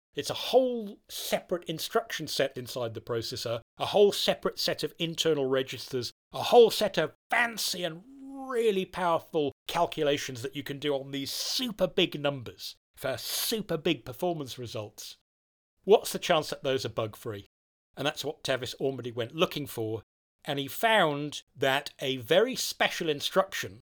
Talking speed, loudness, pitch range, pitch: 160 wpm, -29 LUFS, 130-185 Hz, 145 Hz